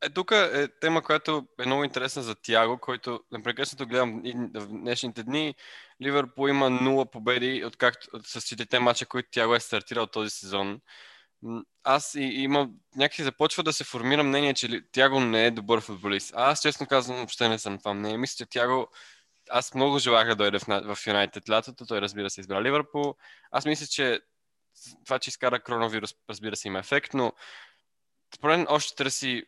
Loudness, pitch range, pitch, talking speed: -27 LUFS, 115-140 Hz, 125 Hz, 175 wpm